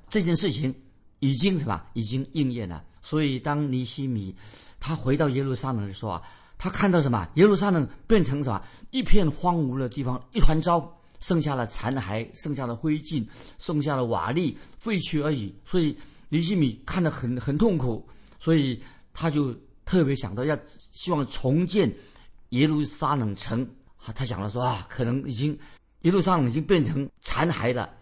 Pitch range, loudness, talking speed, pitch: 120-160 Hz, -26 LUFS, 260 characters per minute, 140 Hz